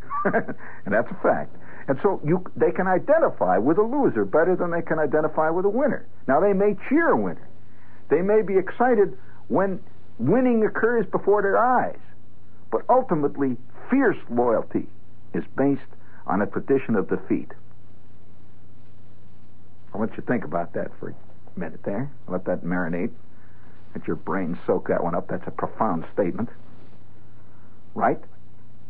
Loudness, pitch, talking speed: -24 LUFS, 140 Hz, 155 wpm